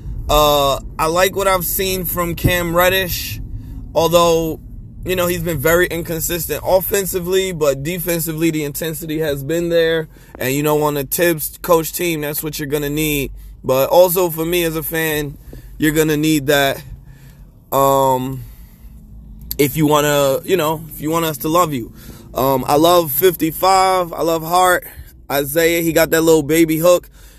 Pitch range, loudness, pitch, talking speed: 145-175 Hz, -16 LUFS, 160 Hz, 165 wpm